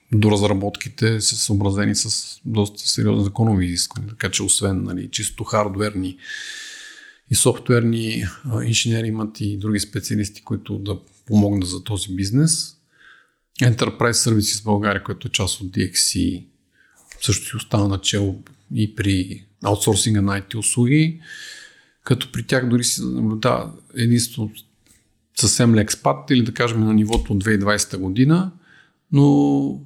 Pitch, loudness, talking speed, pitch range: 110 Hz, -20 LUFS, 130 wpm, 100-120 Hz